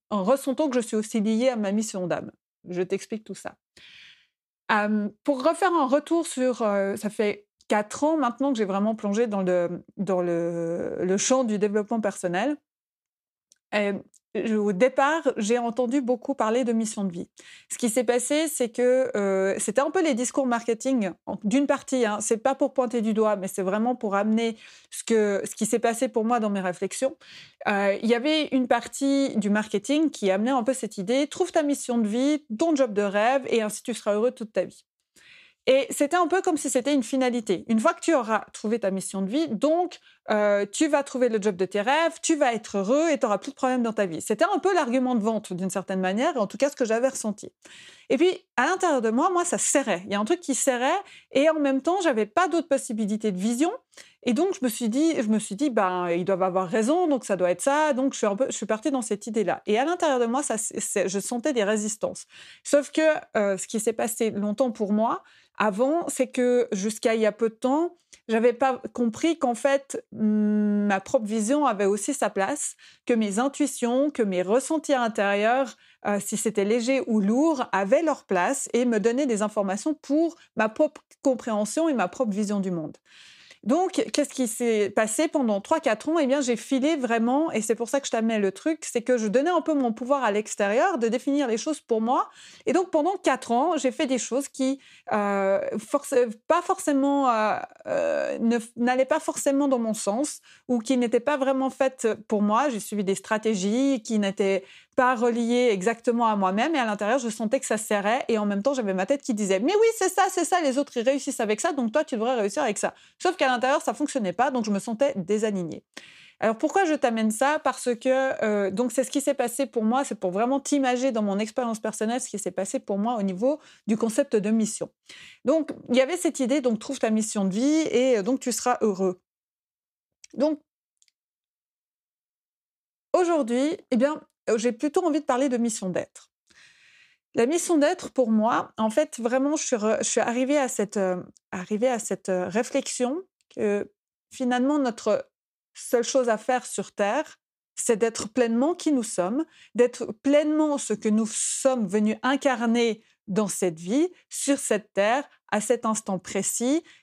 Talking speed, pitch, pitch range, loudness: 215 wpm, 245 Hz, 215-280 Hz, -25 LUFS